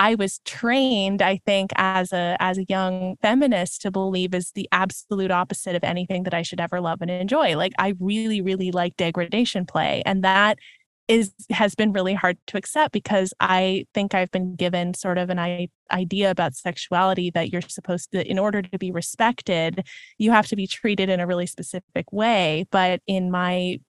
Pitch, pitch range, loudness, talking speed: 185 Hz, 180-200 Hz, -23 LUFS, 190 wpm